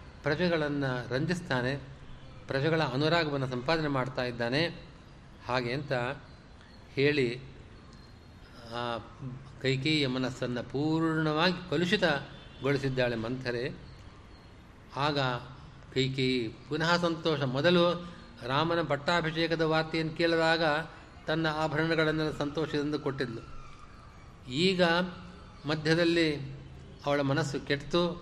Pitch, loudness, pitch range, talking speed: 145 Hz, -30 LUFS, 125-160 Hz, 70 wpm